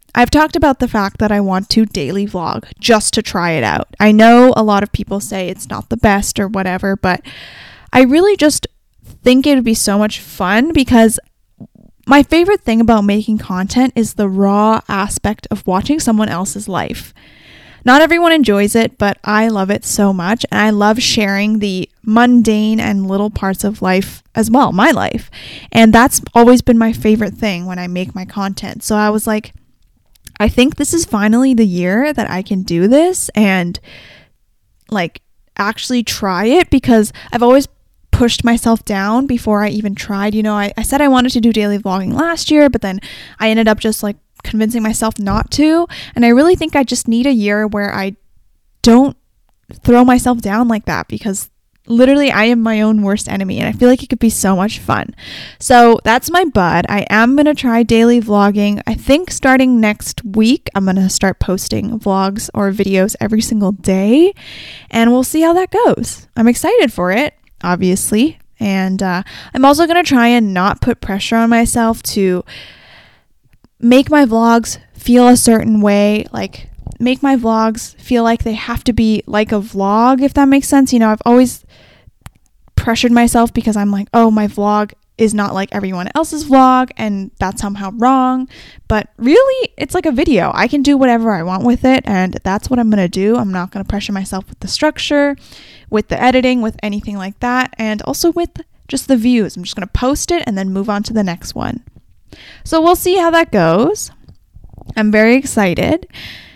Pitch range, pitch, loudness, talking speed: 205-250 Hz, 220 Hz, -13 LUFS, 195 wpm